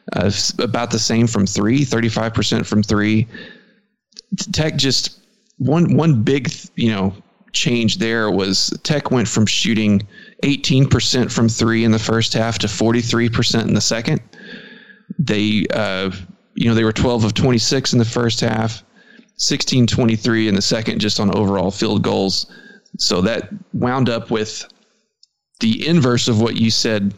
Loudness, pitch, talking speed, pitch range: -17 LUFS, 115 Hz, 150 wpm, 110-155 Hz